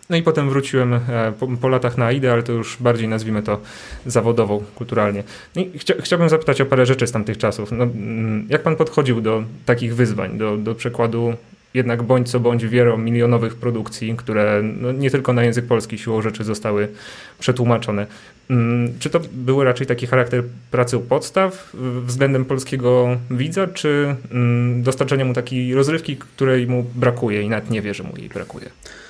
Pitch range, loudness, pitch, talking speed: 115-130 Hz, -19 LUFS, 120 Hz, 175 wpm